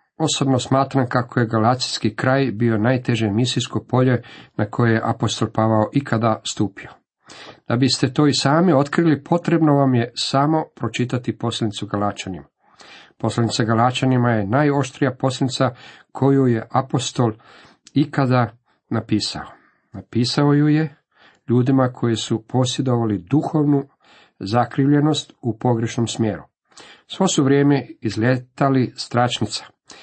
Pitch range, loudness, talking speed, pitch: 115-140 Hz, -19 LUFS, 115 wpm, 125 Hz